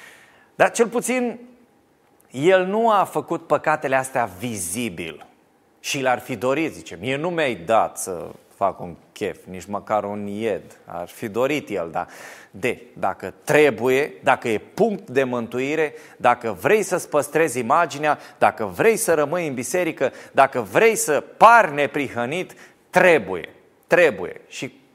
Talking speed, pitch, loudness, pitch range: 140 wpm, 150 Hz, -21 LUFS, 125-190 Hz